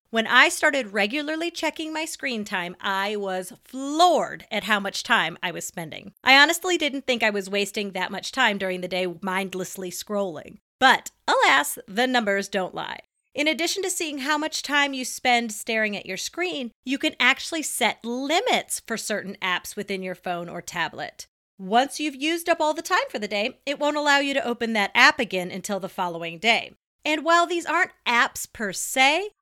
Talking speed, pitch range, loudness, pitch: 195 wpm, 195-305 Hz, -23 LUFS, 240 Hz